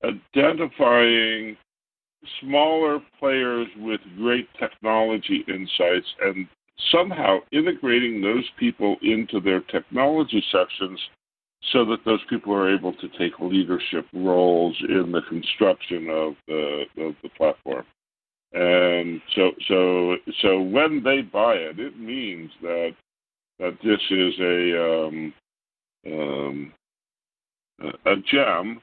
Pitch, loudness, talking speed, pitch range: 95 Hz, -22 LUFS, 110 wpm, 90-120 Hz